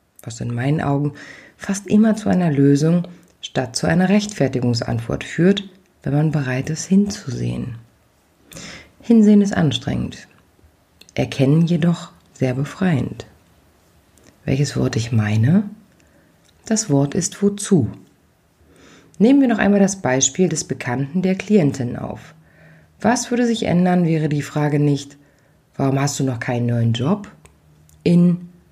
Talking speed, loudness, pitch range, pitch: 125 wpm, -19 LUFS, 120-190 Hz, 145 Hz